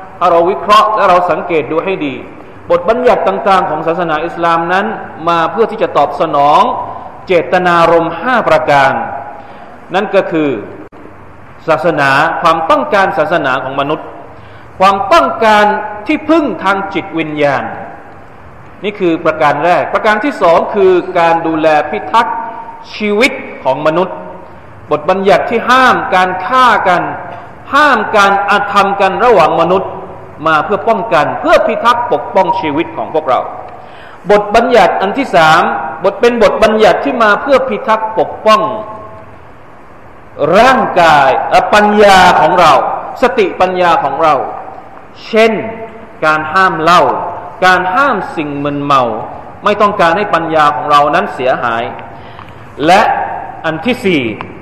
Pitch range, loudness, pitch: 160-215 Hz, -10 LUFS, 190 Hz